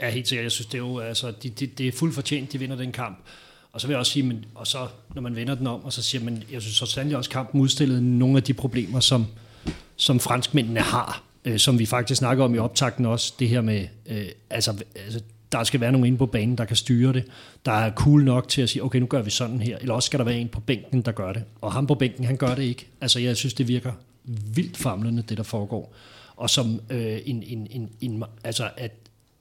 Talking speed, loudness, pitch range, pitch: 265 wpm, -24 LUFS, 115-130 Hz, 125 Hz